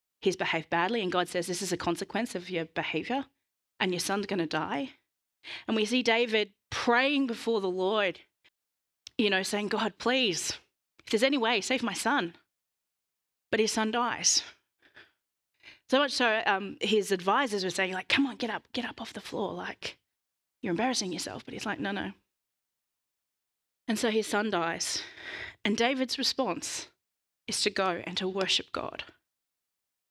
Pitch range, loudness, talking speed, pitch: 185-245 Hz, -29 LUFS, 170 wpm, 215 Hz